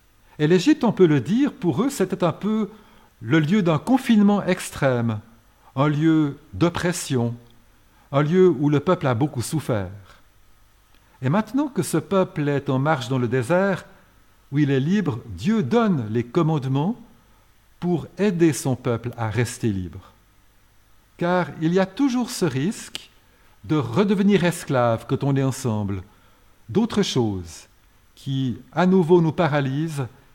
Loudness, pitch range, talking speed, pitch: -22 LUFS, 115-180 Hz, 145 wpm, 145 Hz